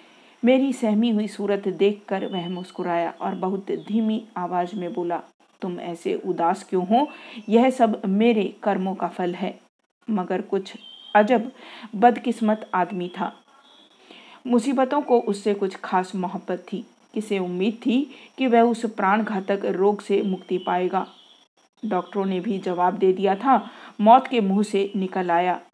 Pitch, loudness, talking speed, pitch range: 200 Hz, -23 LUFS, 150 wpm, 185-235 Hz